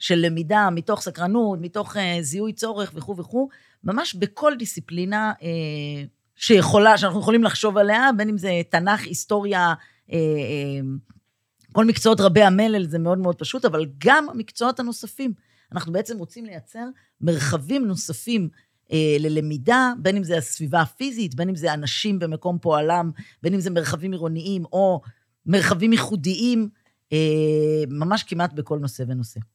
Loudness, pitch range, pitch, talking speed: -21 LUFS, 155-210 Hz, 180 Hz, 130 wpm